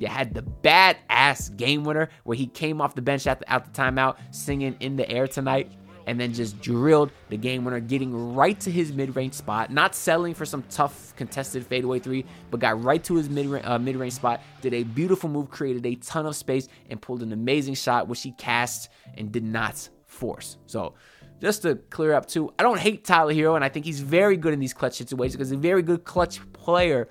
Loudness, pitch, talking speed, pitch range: -24 LUFS, 130 Hz, 230 wpm, 120-155 Hz